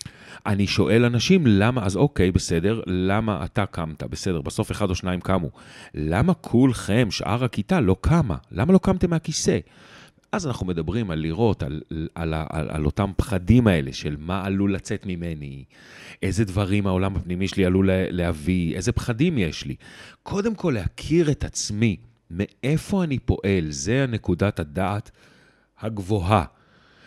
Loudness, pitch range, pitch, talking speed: -23 LUFS, 90-115 Hz, 100 Hz, 150 wpm